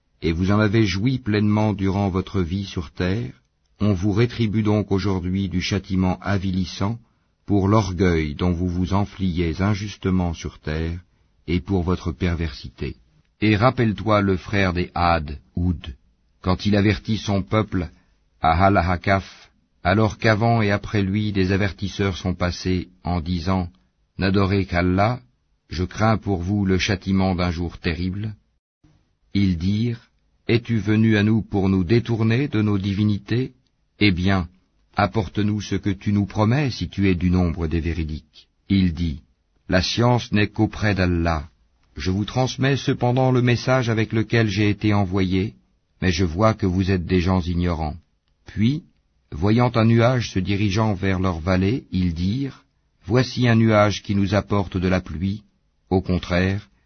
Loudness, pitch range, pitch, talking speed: -22 LUFS, 90-105 Hz, 95 Hz, 150 wpm